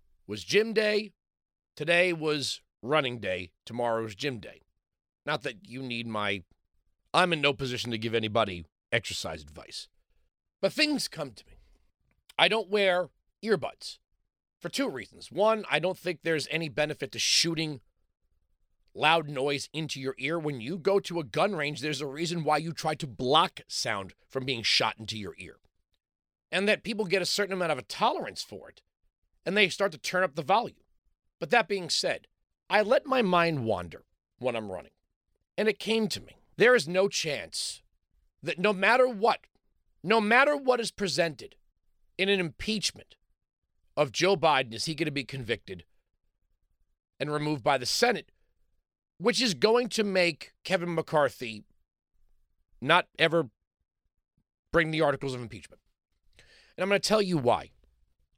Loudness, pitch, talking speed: -28 LUFS, 150 Hz, 165 wpm